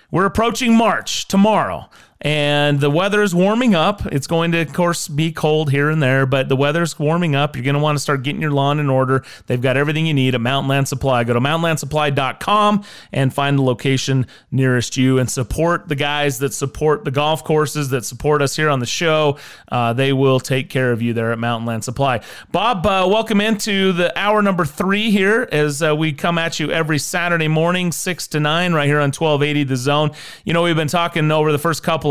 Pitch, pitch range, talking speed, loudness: 150 Hz, 135-170 Hz, 220 wpm, -17 LUFS